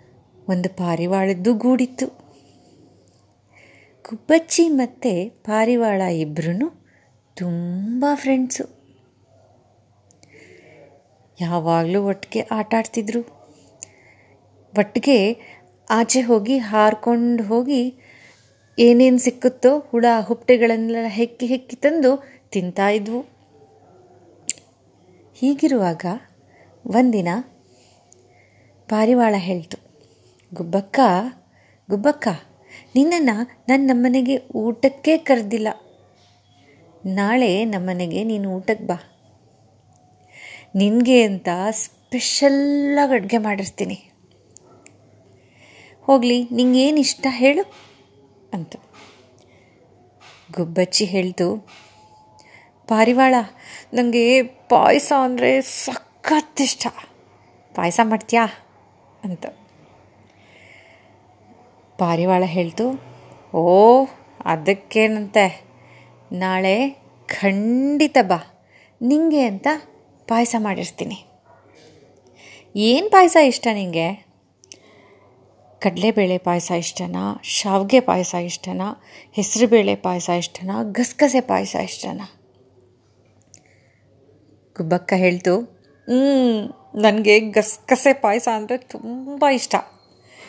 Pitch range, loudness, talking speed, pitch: 170-250 Hz, -19 LUFS, 65 wpm, 215 Hz